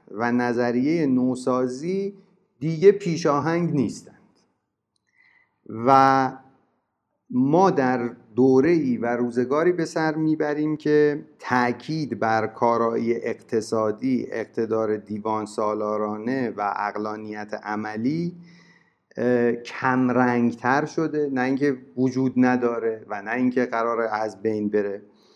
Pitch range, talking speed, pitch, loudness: 115-150 Hz, 95 wpm, 125 Hz, -23 LUFS